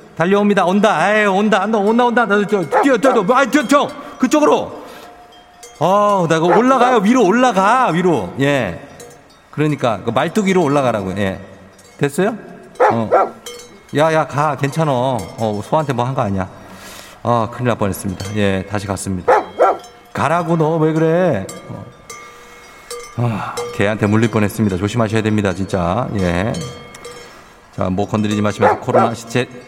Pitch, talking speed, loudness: 140 Hz, 310 characters per minute, -16 LUFS